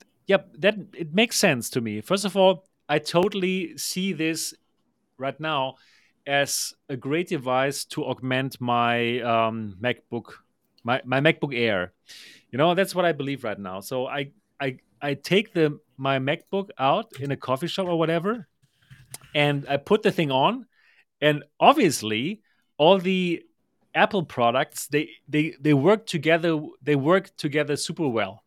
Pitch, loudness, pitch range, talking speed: 150 Hz, -24 LUFS, 130-180 Hz, 155 wpm